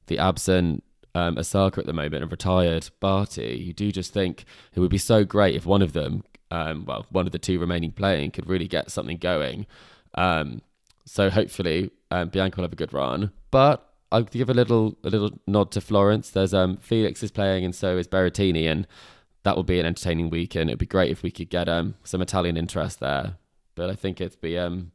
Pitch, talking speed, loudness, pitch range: 95 Hz, 215 wpm, -24 LUFS, 85-100 Hz